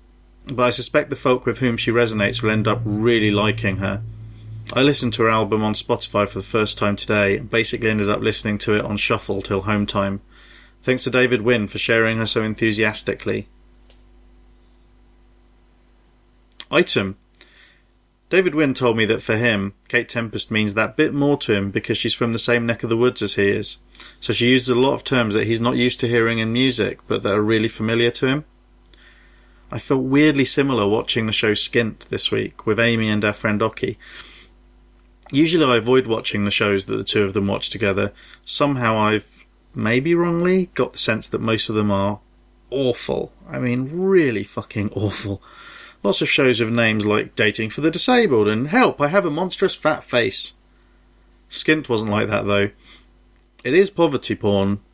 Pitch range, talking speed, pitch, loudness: 105-125 Hz, 190 wpm, 110 Hz, -19 LUFS